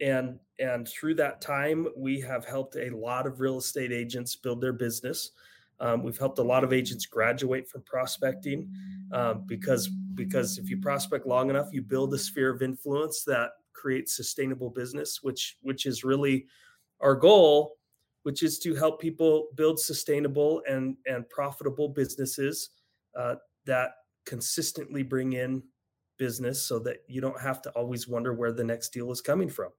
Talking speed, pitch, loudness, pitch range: 165 wpm, 135 Hz, -29 LUFS, 125-150 Hz